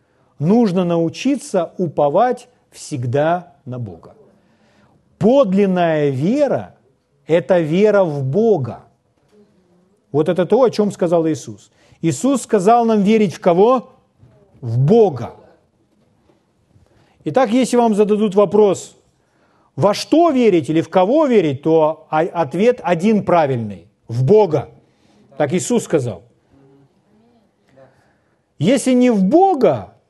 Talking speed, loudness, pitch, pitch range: 105 wpm, -16 LUFS, 175 Hz, 140-215 Hz